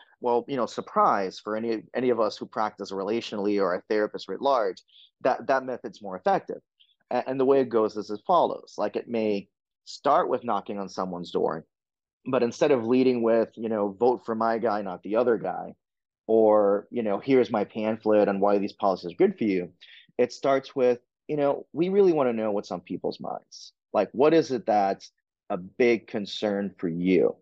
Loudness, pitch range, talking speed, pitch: -26 LUFS, 100-125 Hz, 205 wpm, 110 Hz